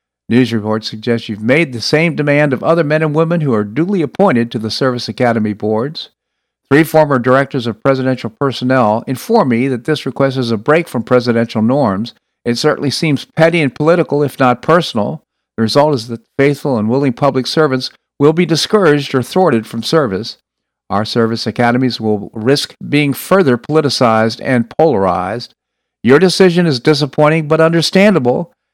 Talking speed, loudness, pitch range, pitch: 165 wpm, -13 LUFS, 115-155 Hz, 130 Hz